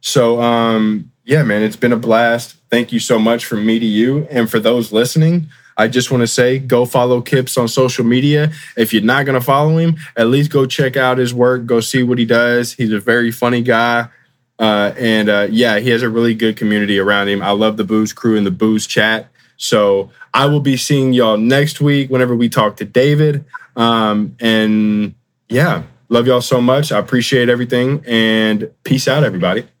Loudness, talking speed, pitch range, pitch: -14 LUFS, 205 wpm, 110-130 Hz, 120 Hz